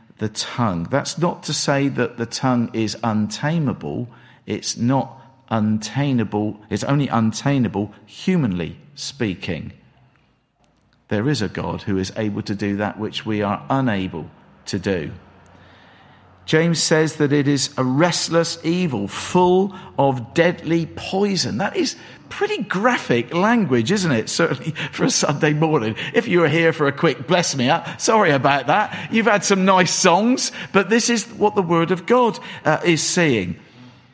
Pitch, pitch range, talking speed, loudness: 145 Hz, 110-175 Hz, 160 wpm, -20 LUFS